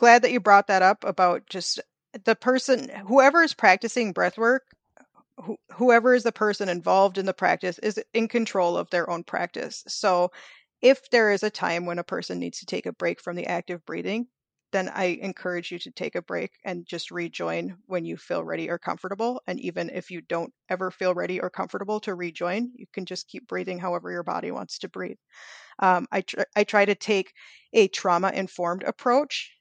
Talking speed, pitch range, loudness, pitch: 205 wpm, 180-230 Hz, -25 LUFS, 195 Hz